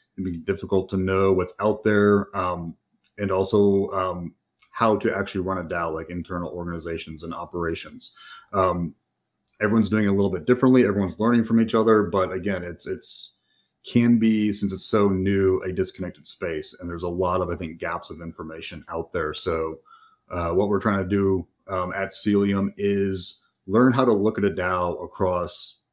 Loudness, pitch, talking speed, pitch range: -24 LUFS, 95 Hz, 185 wpm, 90-100 Hz